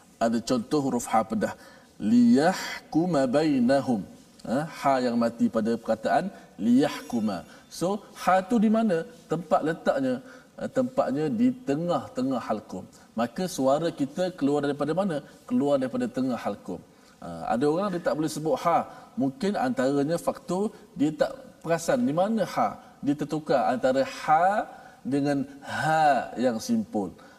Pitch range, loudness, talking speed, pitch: 150-250 Hz, -26 LUFS, 130 wpm, 210 Hz